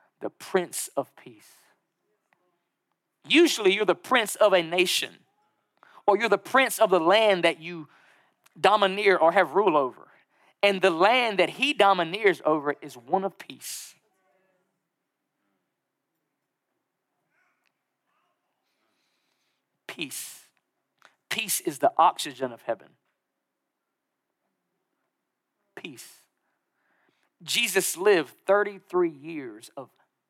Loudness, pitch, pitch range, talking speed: -23 LUFS, 190 Hz, 175-220 Hz, 100 wpm